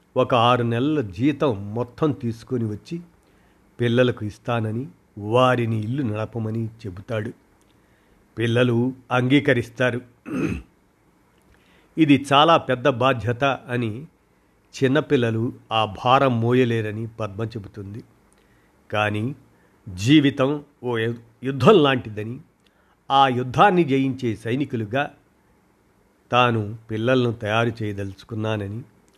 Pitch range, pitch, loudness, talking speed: 110-130 Hz, 120 Hz, -21 LUFS, 80 wpm